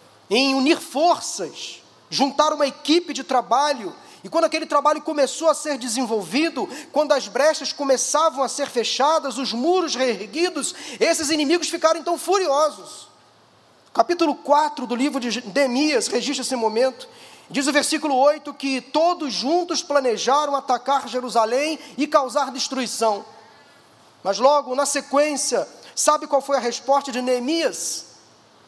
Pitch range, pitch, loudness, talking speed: 260-305 Hz, 285 Hz, -21 LUFS, 135 wpm